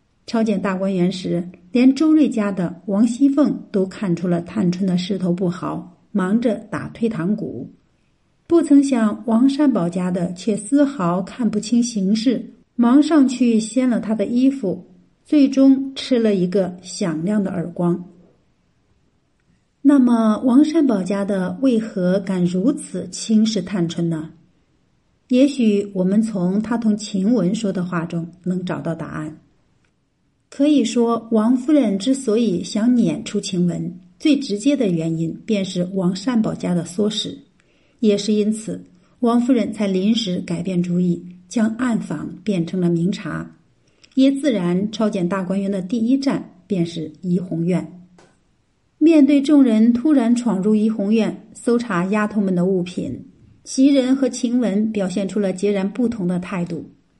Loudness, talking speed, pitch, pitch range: -19 LUFS, 215 characters per minute, 205 Hz, 180-240 Hz